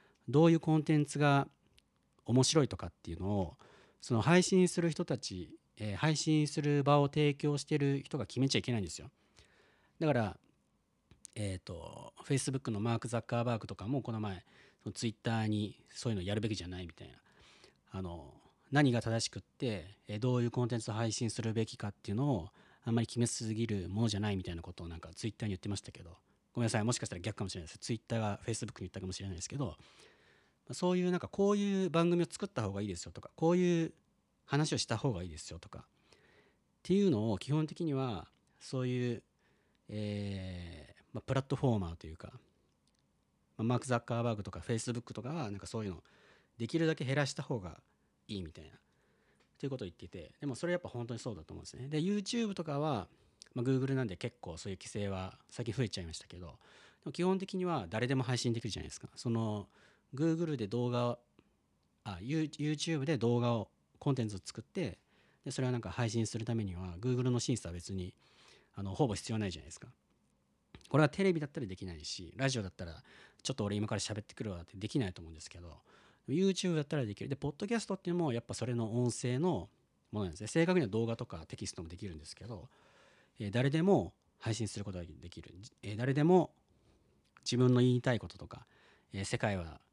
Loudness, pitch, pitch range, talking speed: -35 LUFS, 115 Hz, 100-140 Hz, 450 characters per minute